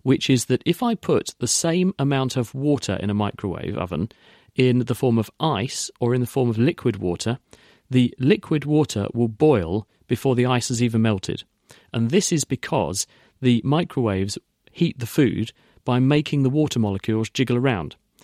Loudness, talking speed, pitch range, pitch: -22 LUFS, 180 wpm, 110-140 Hz, 125 Hz